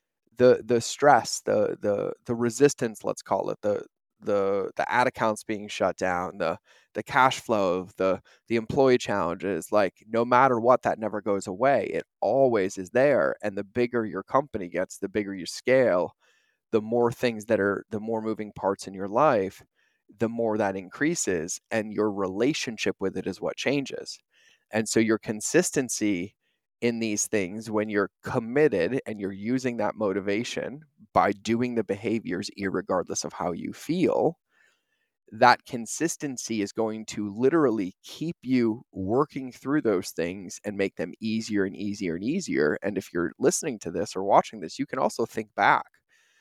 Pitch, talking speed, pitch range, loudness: 110 Hz, 170 wpm, 100-125 Hz, -26 LUFS